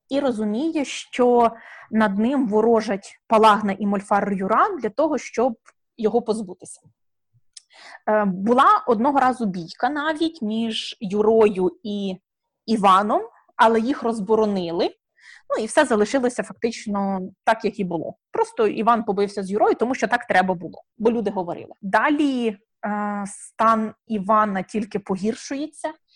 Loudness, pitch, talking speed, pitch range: -21 LUFS, 220 Hz, 125 wpm, 205-245 Hz